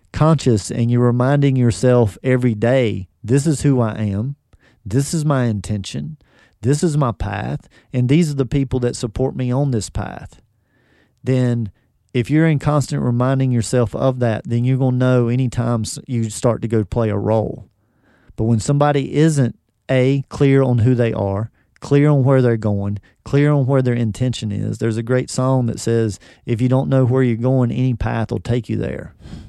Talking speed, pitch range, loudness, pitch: 190 wpm, 115-135 Hz, -18 LUFS, 125 Hz